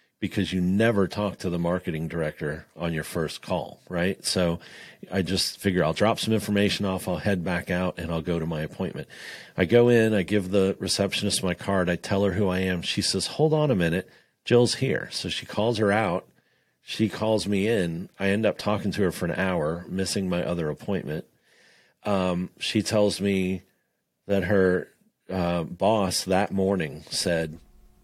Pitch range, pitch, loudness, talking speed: 85-100 Hz, 95 Hz, -25 LUFS, 190 wpm